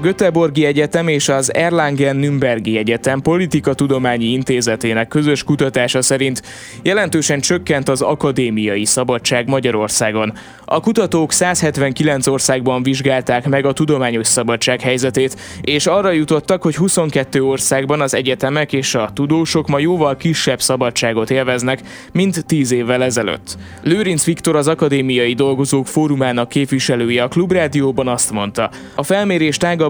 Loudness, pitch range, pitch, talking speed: -15 LUFS, 125-155 Hz, 135 Hz, 125 wpm